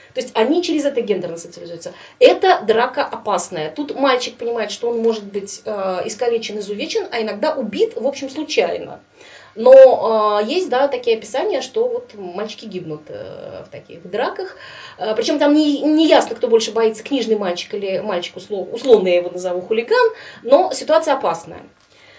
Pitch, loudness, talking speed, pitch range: 235 Hz, -17 LUFS, 155 wpm, 205-320 Hz